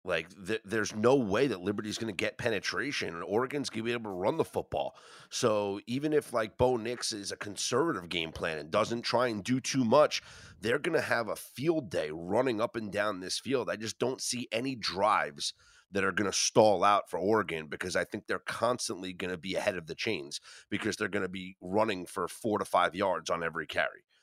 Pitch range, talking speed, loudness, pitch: 95-120 Hz, 230 wpm, -31 LUFS, 110 Hz